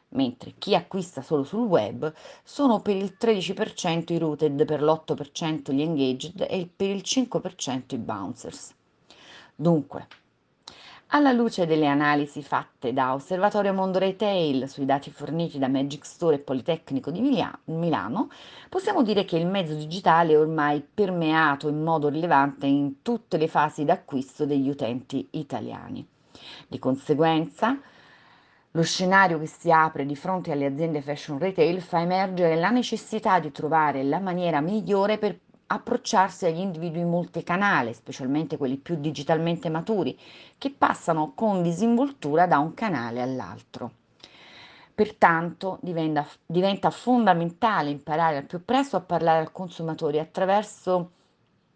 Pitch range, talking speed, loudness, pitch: 150-195 Hz, 135 wpm, -25 LUFS, 165 Hz